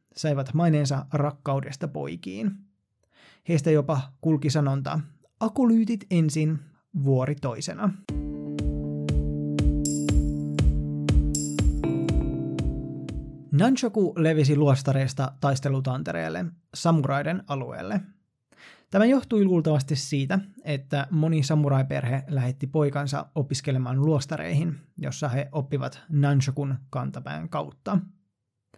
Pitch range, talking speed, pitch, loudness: 125-160 Hz, 75 wpm, 145 Hz, -26 LUFS